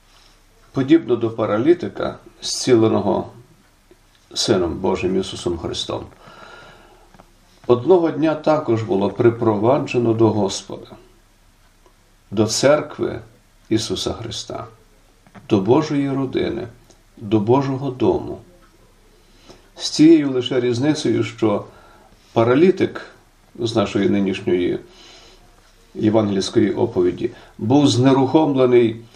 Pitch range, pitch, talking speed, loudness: 110-150 Hz, 125 Hz, 80 wpm, -18 LUFS